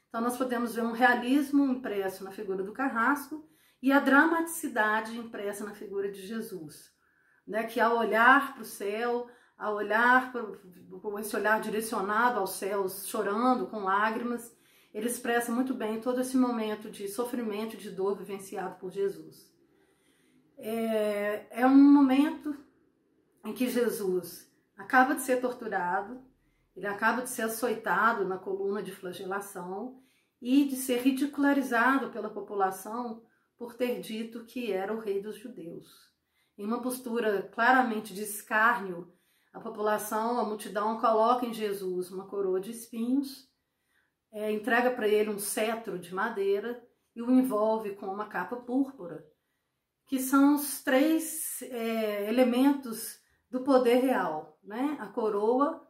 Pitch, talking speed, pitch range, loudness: 225 Hz, 140 wpm, 205-250 Hz, -29 LUFS